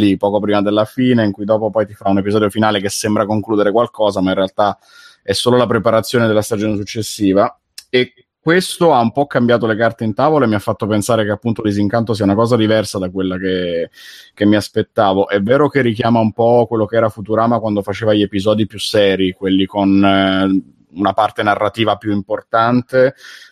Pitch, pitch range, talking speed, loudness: 110 Hz, 100-115 Hz, 200 wpm, -15 LUFS